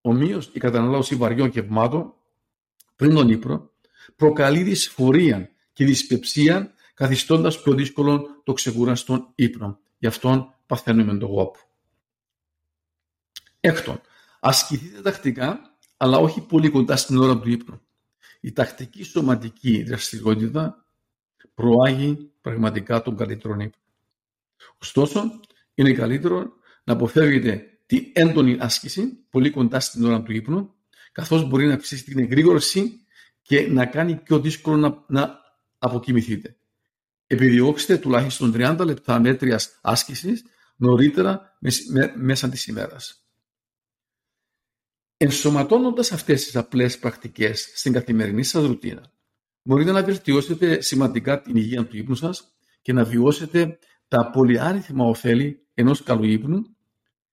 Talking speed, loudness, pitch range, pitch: 115 wpm, -21 LUFS, 115-150 Hz, 130 Hz